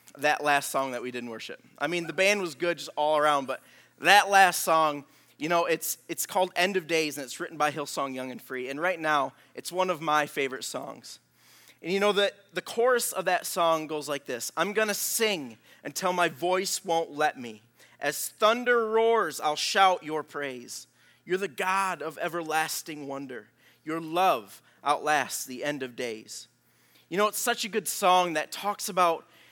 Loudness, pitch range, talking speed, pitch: -27 LUFS, 145-190 Hz, 195 wpm, 165 Hz